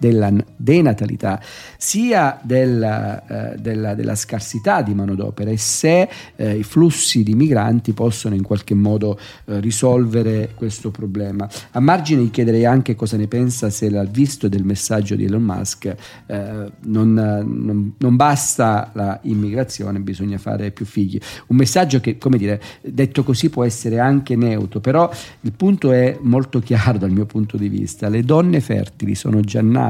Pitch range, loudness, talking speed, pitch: 105-125 Hz, -18 LUFS, 155 wpm, 110 Hz